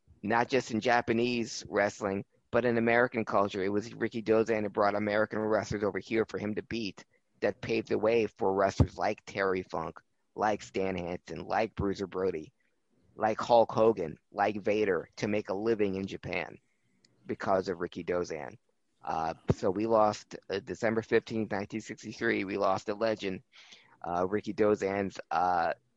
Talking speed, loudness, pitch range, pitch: 160 wpm, -31 LUFS, 100-115 Hz, 105 Hz